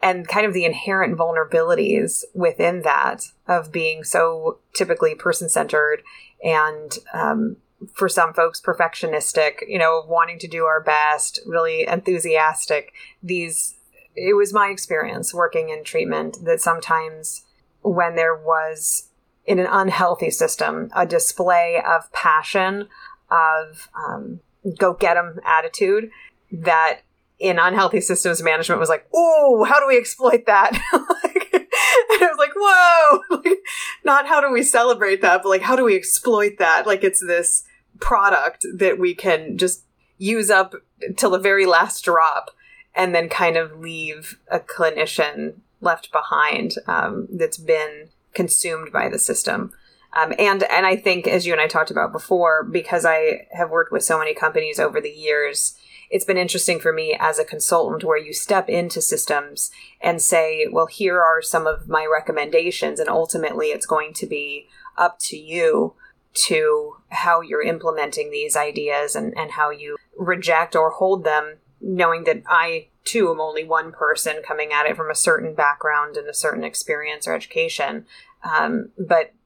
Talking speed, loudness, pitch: 160 wpm, -19 LUFS, 185 Hz